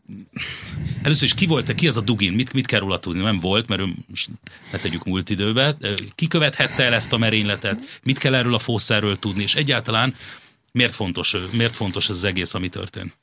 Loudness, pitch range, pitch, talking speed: -20 LUFS, 100-130 Hz, 110 Hz, 215 wpm